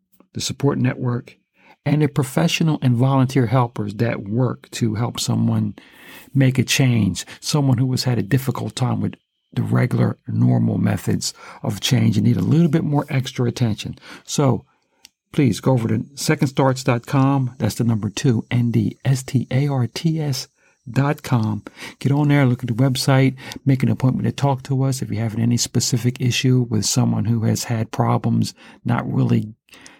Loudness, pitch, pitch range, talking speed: -20 LUFS, 125 Hz, 115-135 Hz, 155 wpm